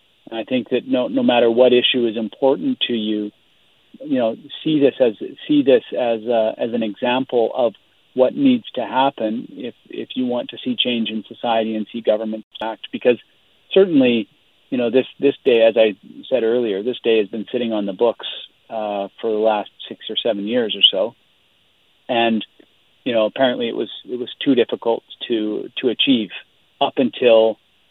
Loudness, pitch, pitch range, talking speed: -19 LUFS, 115 Hz, 110-125 Hz, 185 wpm